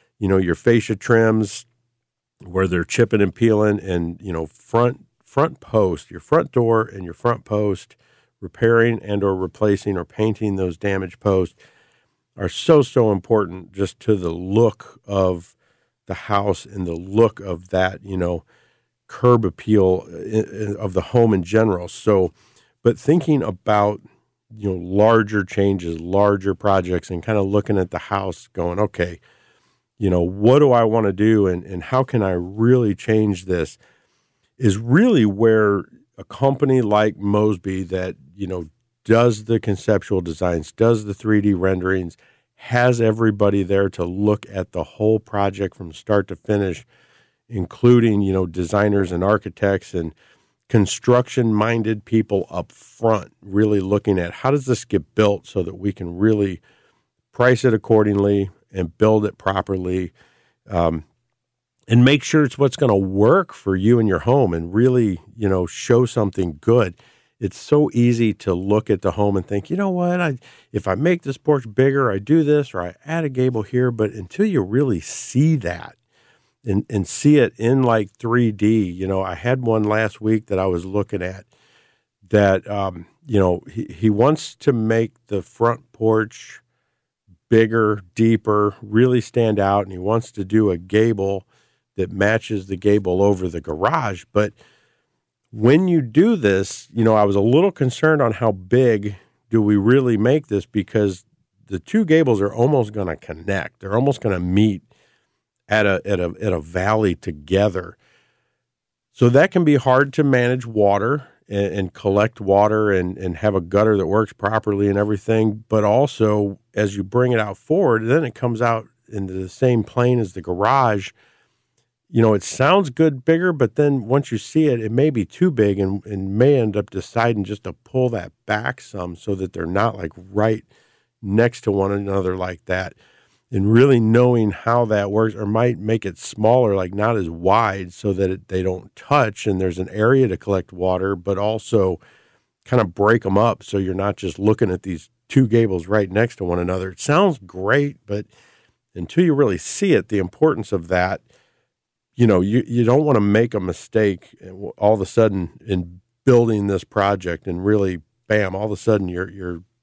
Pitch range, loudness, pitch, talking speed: 95-120 Hz, -19 LUFS, 105 Hz, 180 wpm